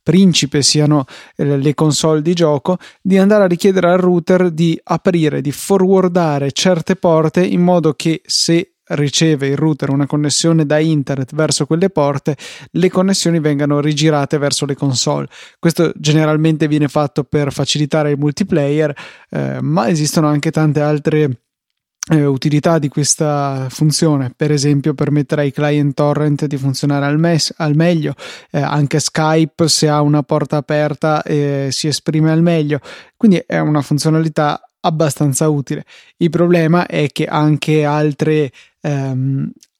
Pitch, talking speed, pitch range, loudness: 150 Hz, 145 wpm, 145-165 Hz, -14 LUFS